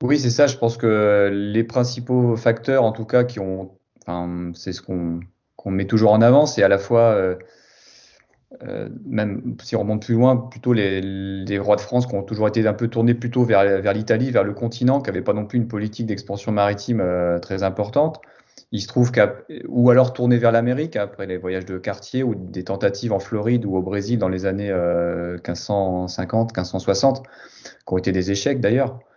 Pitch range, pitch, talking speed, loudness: 95-120 Hz, 105 Hz, 205 wpm, -20 LUFS